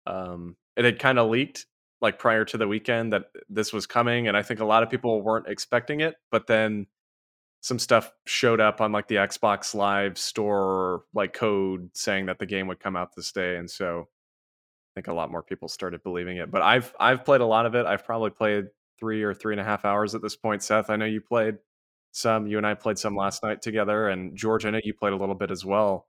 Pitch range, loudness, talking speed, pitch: 100-110 Hz, -25 LUFS, 240 wpm, 105 Hz